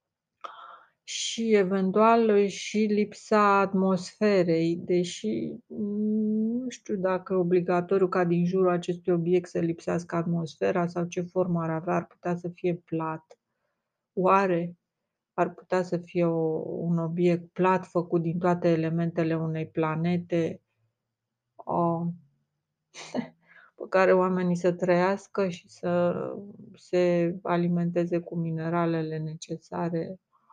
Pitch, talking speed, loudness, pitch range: 175 Hz, 110 wpm, -27 LUFS, 170-190 Hz